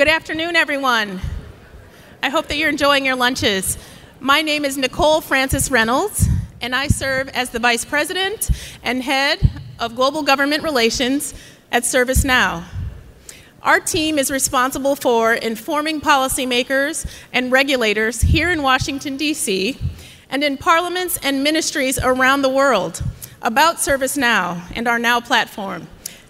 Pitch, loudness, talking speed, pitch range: 275 Hz, -17 LUFS, 130 wpm, 250-300 Hz